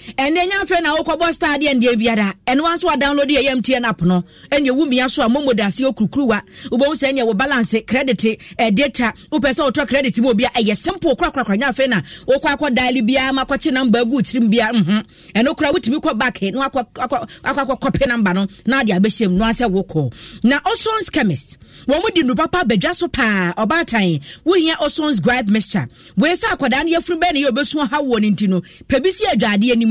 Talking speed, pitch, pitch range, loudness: 180 wpm, 255 Hz, 220-290 Hz, -16 LUFS